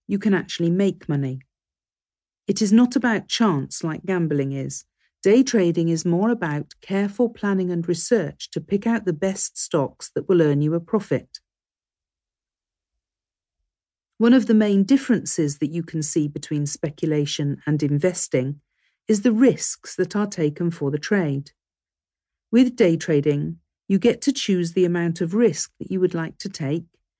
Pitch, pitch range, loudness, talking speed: 170 Hz, 145-200 Hz, -22 LUFS, 160 wpm